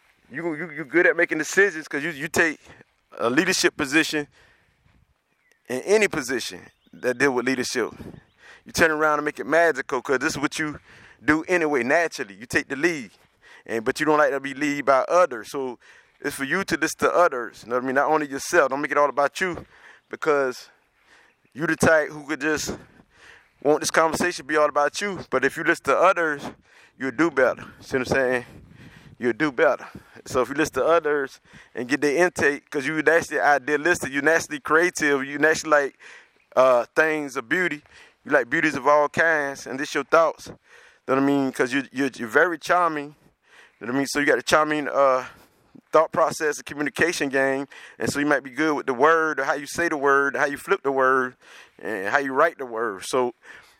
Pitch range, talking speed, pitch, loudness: 140-160 Hz, 215 wpm, 150 Hz, -22 LUFS